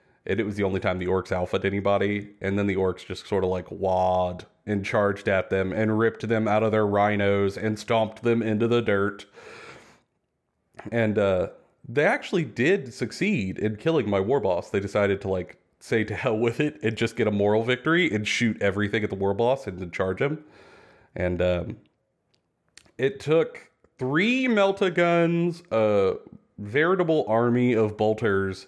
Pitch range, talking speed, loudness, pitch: 100-120 Hz, 180 wpm, -25 LUFS, 105 Hz